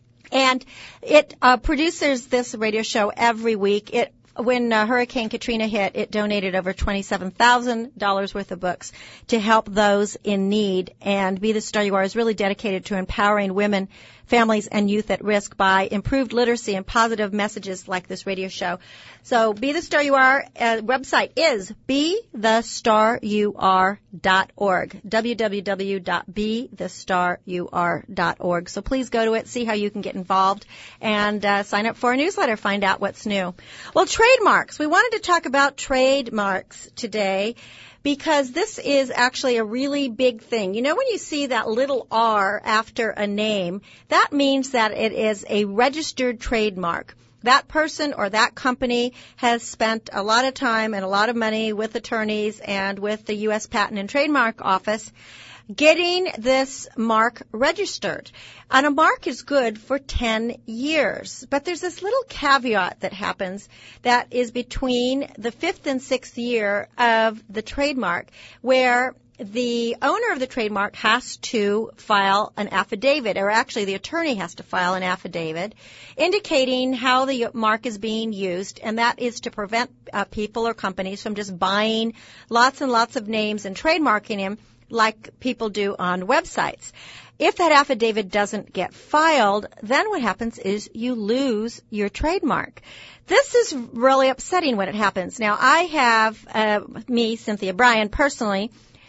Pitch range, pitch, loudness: 205-260 Hz, 225 Hz, -21 LUFS